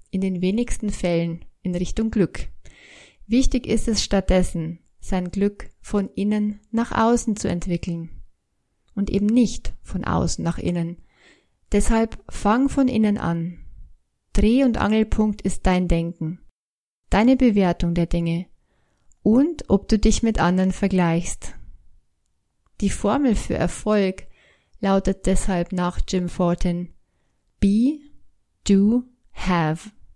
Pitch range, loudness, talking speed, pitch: 175-220 Hz, -22 LUFS, 120 wpm, 195 Hz